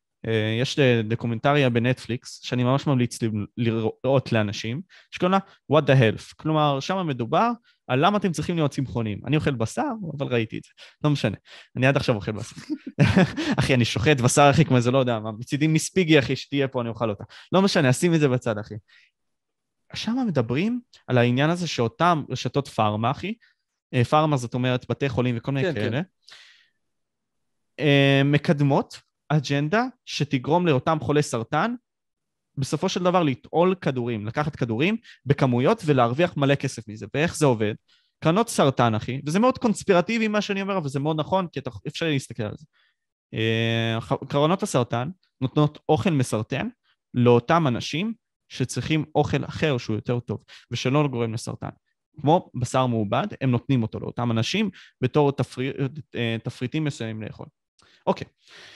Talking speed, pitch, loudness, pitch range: 155 wpm, 140 Hz, -23 LUFS, 120-160 Hz